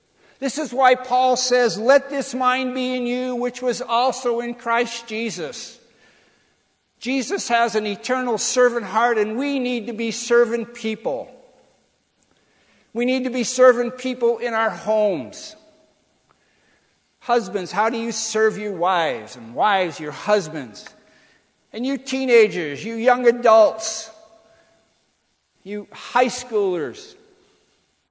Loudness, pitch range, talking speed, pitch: -20 LUFS, 220-255 Hz, 125 wpm, 240 Hz